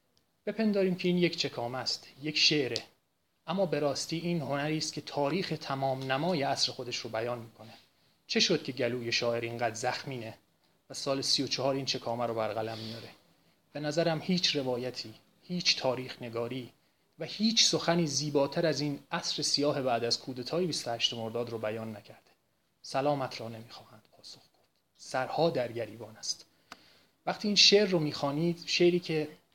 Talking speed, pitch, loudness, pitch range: 160 wpm, 140 Hz, -30 LUFS, 120-165 Hz